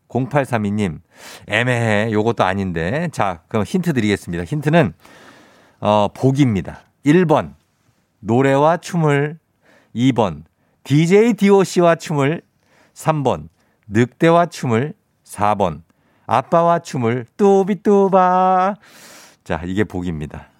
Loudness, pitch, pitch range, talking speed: -17 LUFS, 125 Hz, 105-170 Hz, 195 characters per minute